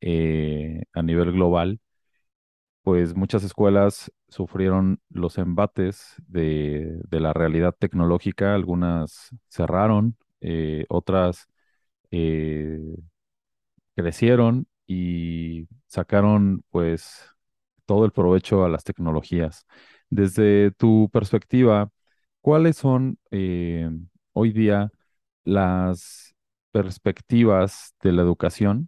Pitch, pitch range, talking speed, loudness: 95 Hz, 85-105 Hz, 90 wpm, -22 LUFS